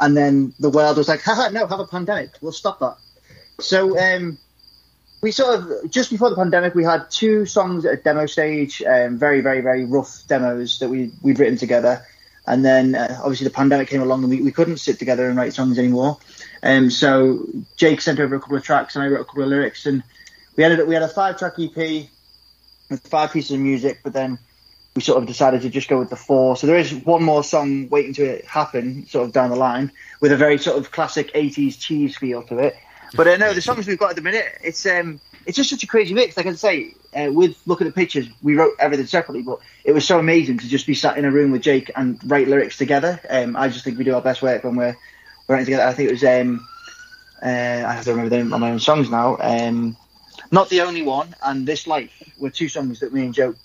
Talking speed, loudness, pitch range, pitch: 250 wpm, -18 LUFS, 130-165 Hz, 140 Hz